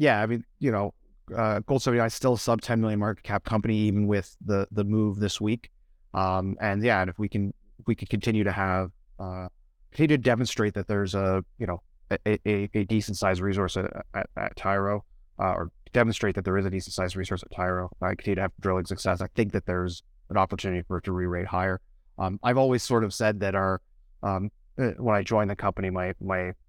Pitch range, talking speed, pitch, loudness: 95-110 Hz, 230 wpm, 100 Hz, -27 LUFS